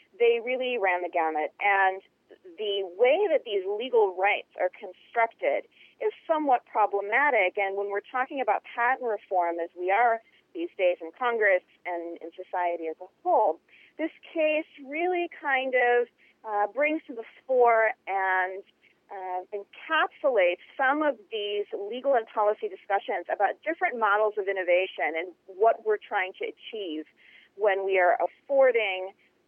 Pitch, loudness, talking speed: 230 Hz, -27 LUFS, 145 wpm